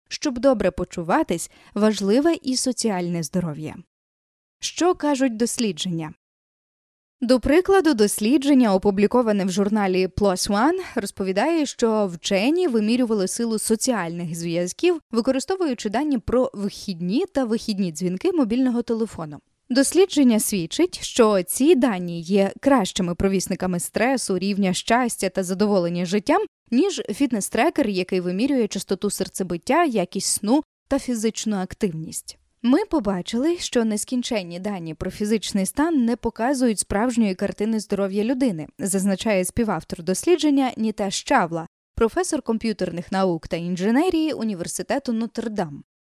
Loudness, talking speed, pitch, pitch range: -22 LUFS, 110 wpm, 215 Hz, 190-265 Hz